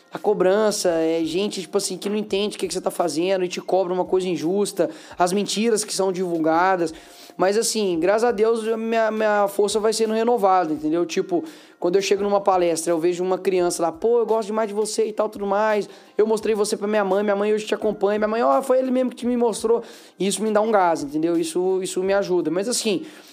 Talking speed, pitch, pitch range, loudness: 235 wpm, 200 Hz, 180-220 Hz, -21 LUFS